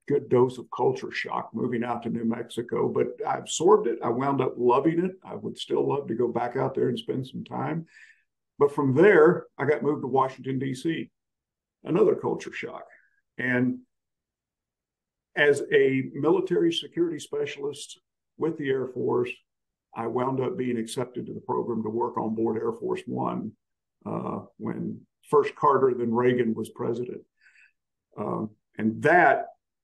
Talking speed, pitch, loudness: 160 wpm, 135 Hz, -26 LUFS